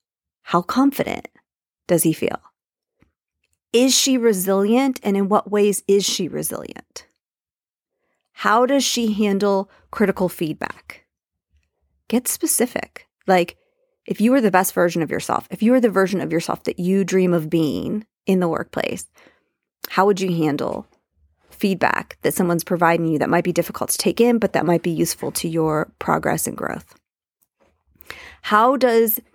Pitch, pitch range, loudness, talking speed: 190 Hz, 165-230 Hz, -19 LUFS, 155 wpm